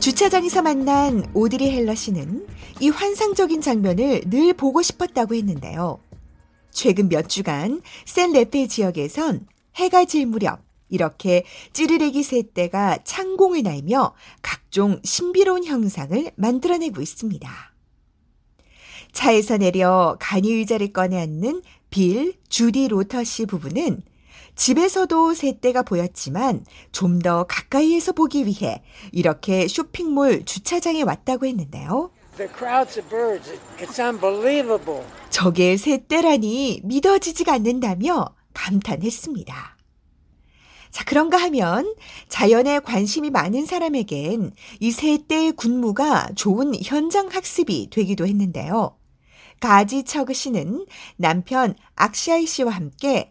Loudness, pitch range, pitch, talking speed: -20 LUFS, 195-300 Hz, 245 Hz, 250 characters per minute